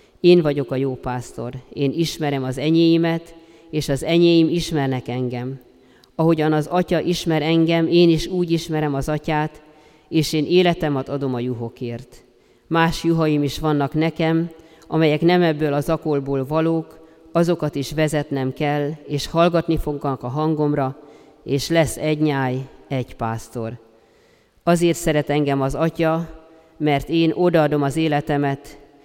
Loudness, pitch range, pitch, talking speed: -20 LUFS, 140-165 Hz, 155 Hz, 140 wpm